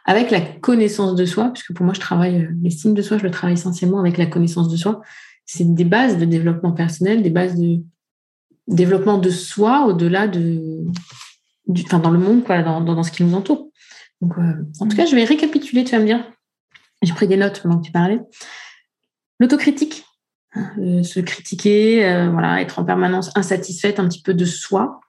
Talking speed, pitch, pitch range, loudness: 200 wpm, 185 Hz, 175-210 Hz, -17 LUFS